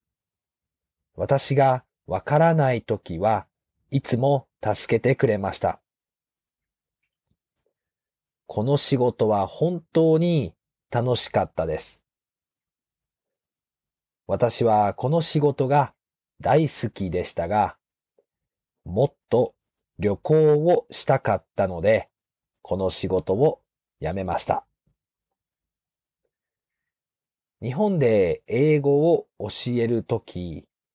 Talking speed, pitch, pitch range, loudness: 165 characters per minute, 125 Hz, 95-150 Hz, -23 LUFS